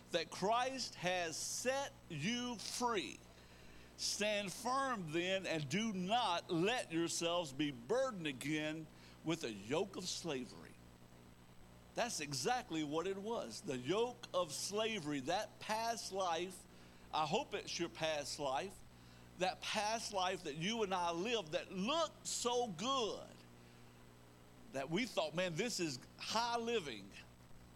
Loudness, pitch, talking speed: -40 LUFS, 170 Hz, 130 wpm